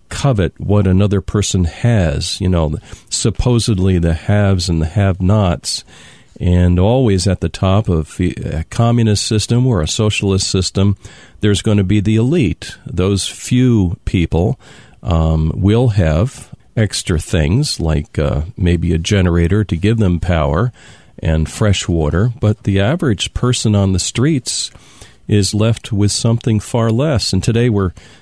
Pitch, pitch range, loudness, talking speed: 100 Hz, 90-115 Hz, -15 LUFS, 145 wpm